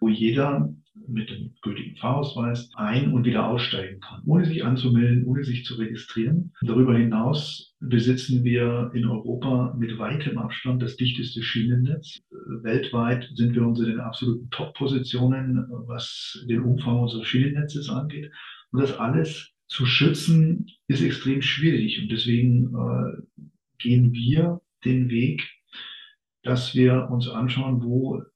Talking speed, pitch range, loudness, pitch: 135 wpm, 120-135 Hz, -24 LUFS, 125 Hz